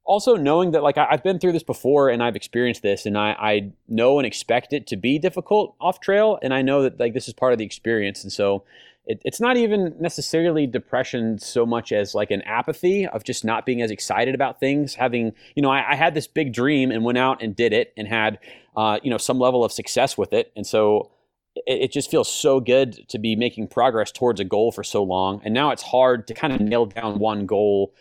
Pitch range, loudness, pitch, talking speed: 110-150 Hz, -21 LUFS, 125 Hz, 240 wpm